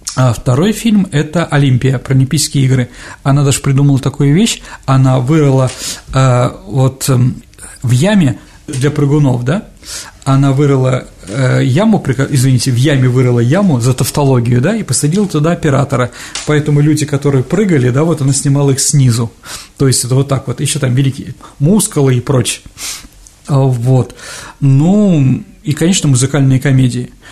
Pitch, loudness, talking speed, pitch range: 135 Hz, -12 LUFS, 145 wpm, 130-150 Hz